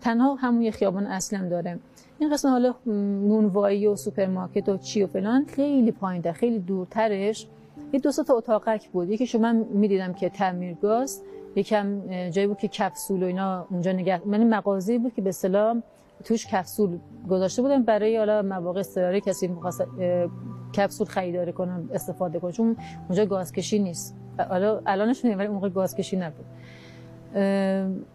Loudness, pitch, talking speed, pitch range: -25 LUFS, 200 Hz, 160 wpm, 185-220 Hz